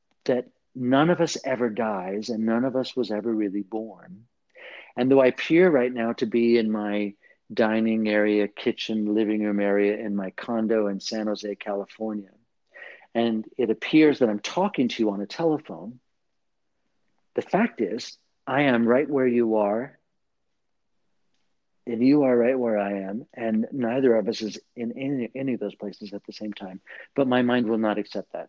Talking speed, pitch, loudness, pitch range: 180 wpm, 110 Hz, -24 LUFS, 105-125 Hz